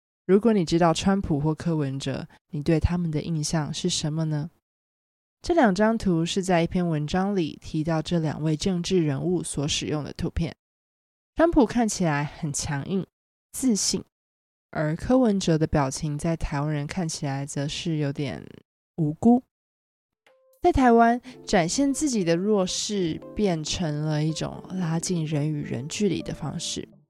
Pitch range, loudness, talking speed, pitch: 150-195 Hz, -25 LUFS, 230 characters per minute, 165 Hz